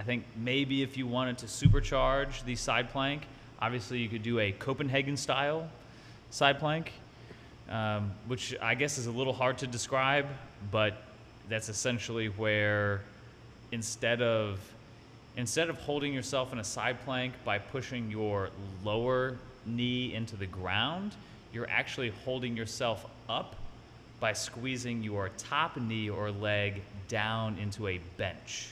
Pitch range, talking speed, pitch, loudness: 110-130 Hz, 140 wpm, 120 Hz, -33 LUFS